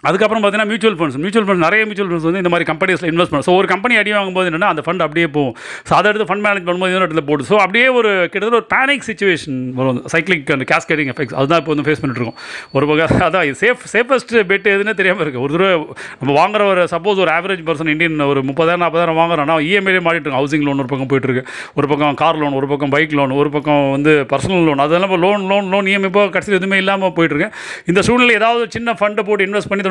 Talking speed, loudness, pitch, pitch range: 230 wpm, -14 LUFS, 175 Hz, 150-200 Hz